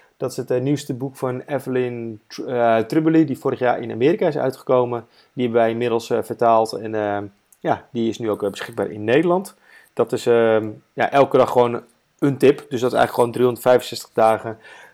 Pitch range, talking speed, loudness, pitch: 115-135 Hz, 195 wpm, -20 LUFS, 125 Hz